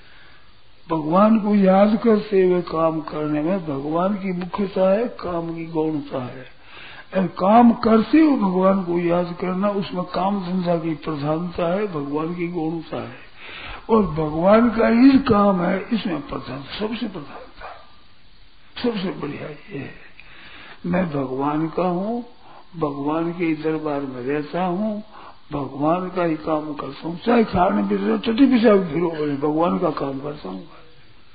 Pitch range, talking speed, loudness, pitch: 155-205 Hz, 140 wpm, -20 LUFS, 175 Hz